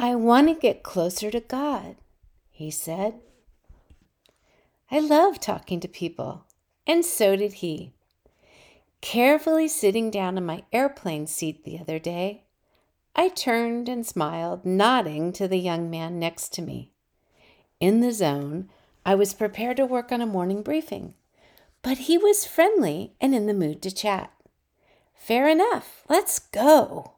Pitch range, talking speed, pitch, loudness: 170-260 Hz, 145 wpm, 205 Hz, -24 LUFS